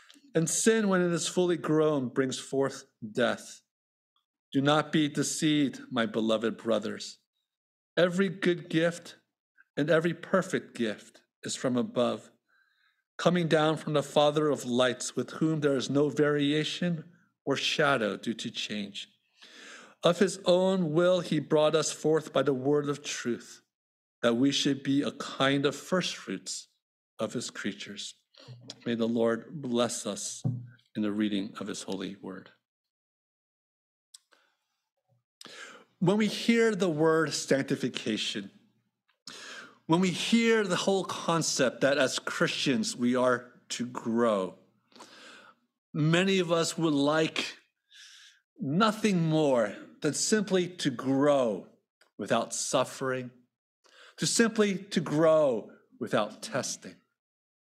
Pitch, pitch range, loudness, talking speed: 155 Hz, 130-180 Hz, -28 LUFS, 125 wpm